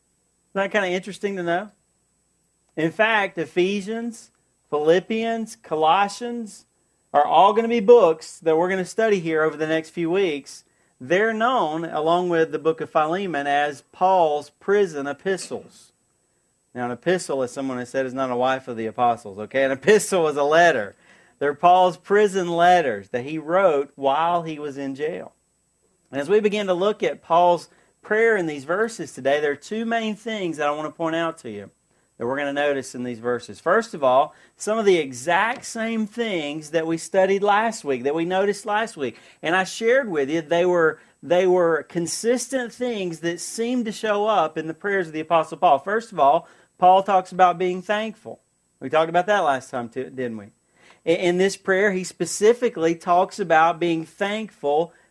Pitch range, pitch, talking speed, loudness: 150-205 Hz, 175 Hz, 190 wpm, -22 LUFS